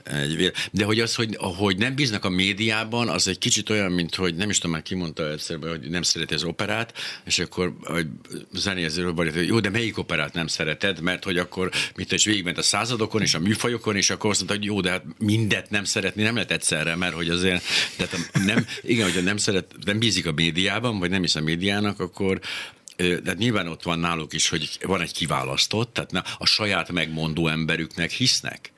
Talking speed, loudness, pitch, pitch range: 200 wpm, -23 LUFS, 95 Hz, 85-105 Hz